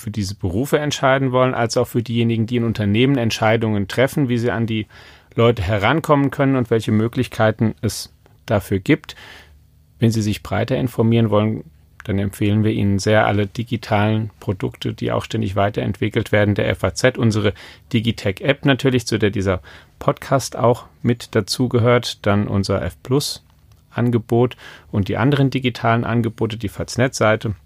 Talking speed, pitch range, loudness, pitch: 150 wpm, 105-120 Hz, -19 LUFS, 110 Hz